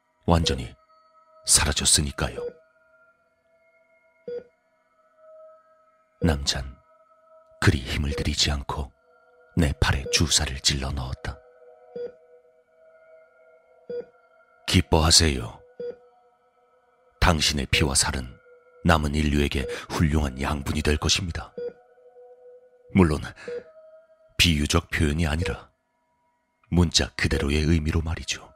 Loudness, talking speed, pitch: -23 LUFS, 175 characters per minute, 160 Hz